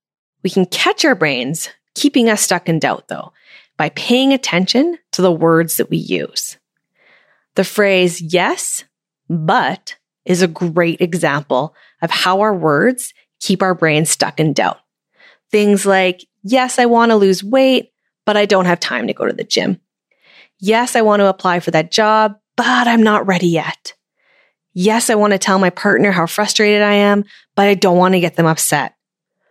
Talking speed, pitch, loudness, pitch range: 180 wpm, 195 Hz, -14 LUFS, 175-215 Hz